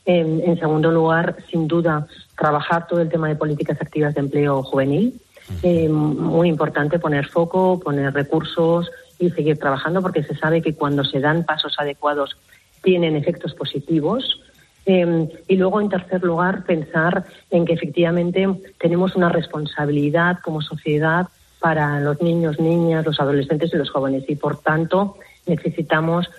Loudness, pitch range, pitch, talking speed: -20 LUFS, 150-175 Hz, 165 Hz, 150 wpm